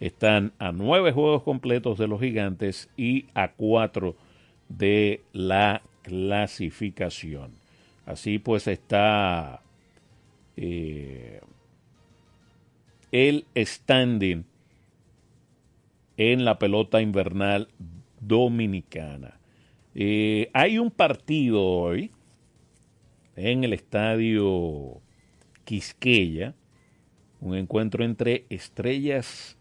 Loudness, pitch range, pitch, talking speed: -25 LUFS, 95-120 Hz, 105 Hz, 75 wpm